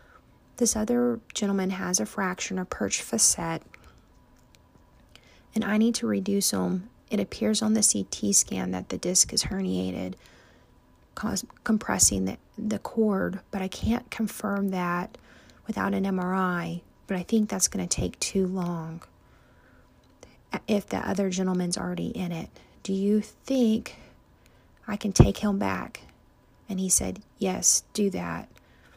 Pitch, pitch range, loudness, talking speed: 195 Hz, 180-215 Hz, -26 LUFS, 140 wpm